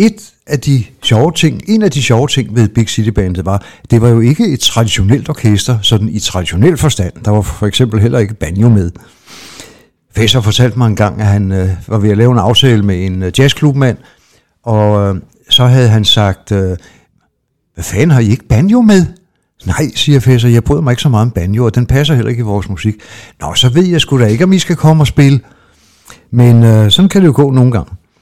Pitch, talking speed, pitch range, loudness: 115 Hz, 230 wpm, 105-135 Hz, -10 LUFS